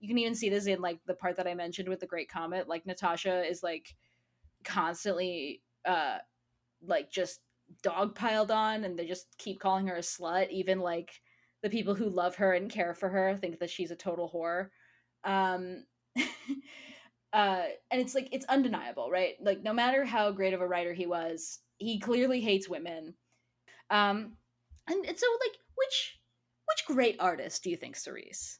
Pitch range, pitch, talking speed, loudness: 170-220 Hz, 185 Hz, 185 wpm, -33 LUFS